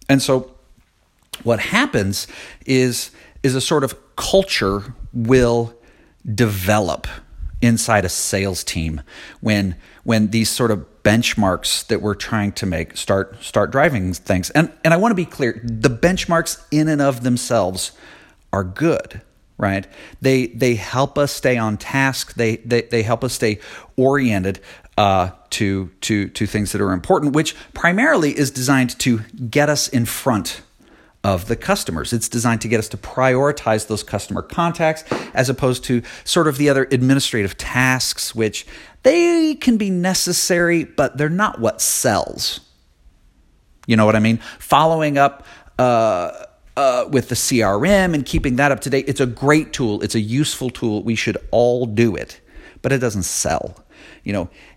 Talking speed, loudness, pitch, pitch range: 160 wpm, -18 LUFS, 120 Hz, 105-145 Hz